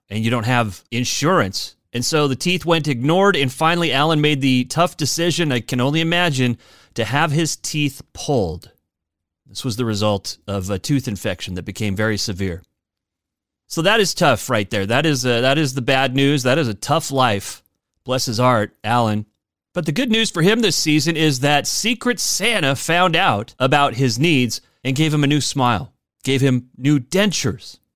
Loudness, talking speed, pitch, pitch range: -18 LUFS, 190 wpm, 135 Hz, 110-160 Hz